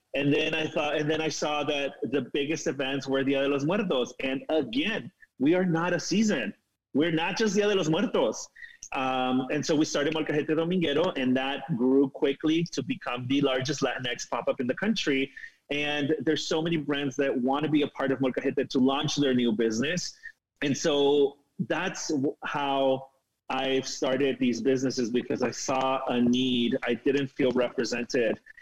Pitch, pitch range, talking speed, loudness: 140 Hz, 130-155 Hz, 185 wpm, -27 LUFS